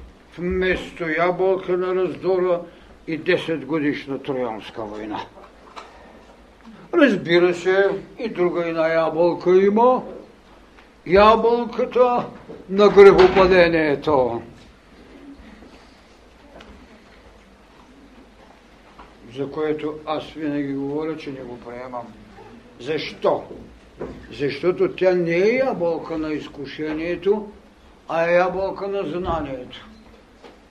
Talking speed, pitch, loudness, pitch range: 80 wpm, 170 Hz, -20 LUFS, 145-185 Hz